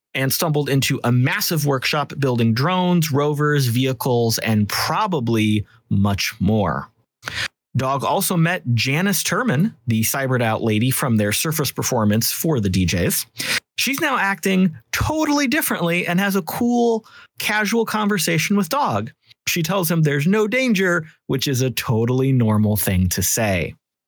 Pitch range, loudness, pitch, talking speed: 115-185 Hz, -19 LUFS, 140 Hz, 140 wpm